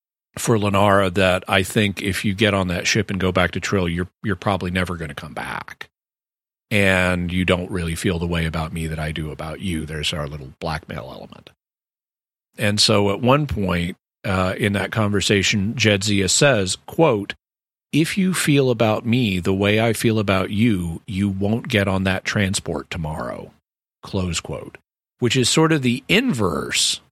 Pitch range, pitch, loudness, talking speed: 90-110 Hz, 100 Hz, -20 LUFS, 180 wpm